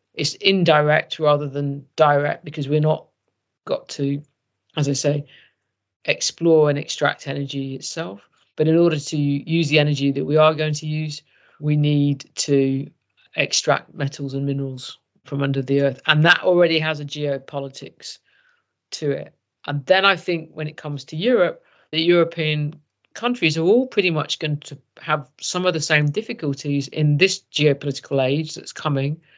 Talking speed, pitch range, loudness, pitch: 165 wpm, 140-160 Hz, -20 LUFS, 150 Hz